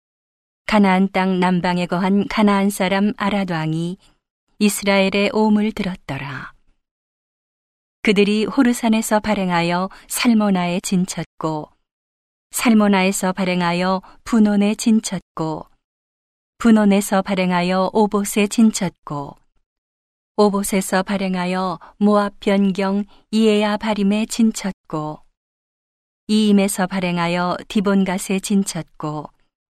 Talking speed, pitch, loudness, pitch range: 230 characters per minute, 195 Hz, -18 LUFS, 180-210 Hz